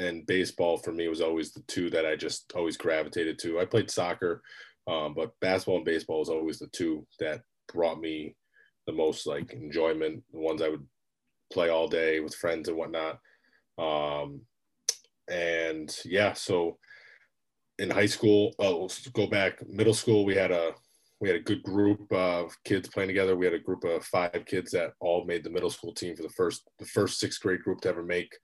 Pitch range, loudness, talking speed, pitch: 80-110 Hz, -30 LUFS, 200 wpm, 90 Hz